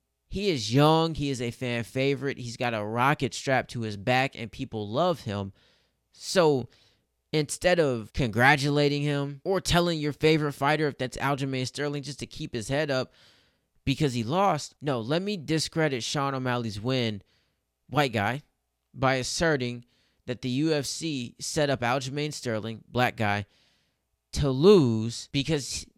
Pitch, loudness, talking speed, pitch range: 135 Hz, -27 LUFS, 150 wpm, 120-150 Hz